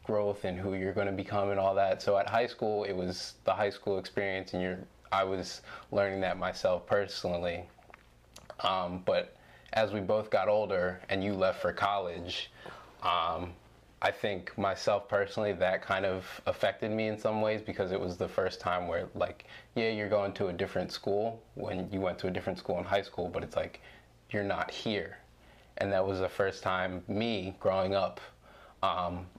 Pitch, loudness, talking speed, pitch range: 100 Hz, -33 LUFS, 190 wpm, 95-105 Hz